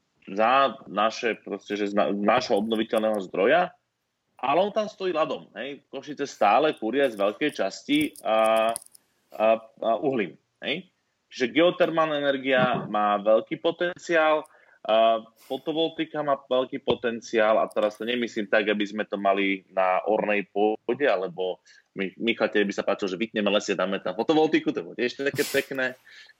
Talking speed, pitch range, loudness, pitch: 150 wpm, 105-150 Hz, -25 LUFS, 115 Hz